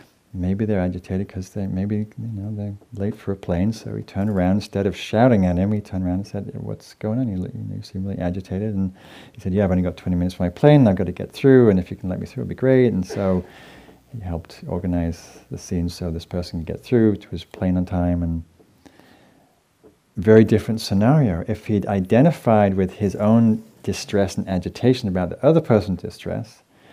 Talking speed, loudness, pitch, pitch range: 220 wpm, -21 LUFS, 100 Hz, 90-110 Hz